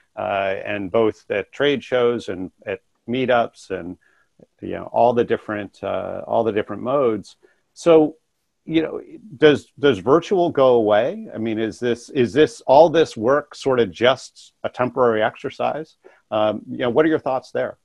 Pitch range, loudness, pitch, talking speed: 110-155 Hz, -20 LUFS, 120 Hz, 170 wpm